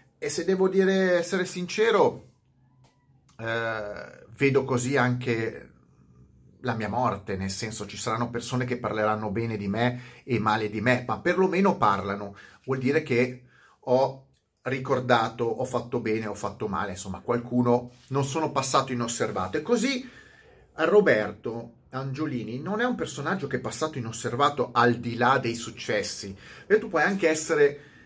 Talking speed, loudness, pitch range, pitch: 150 wpm, -26 LUFS, 115-140 Hz, 125 Hz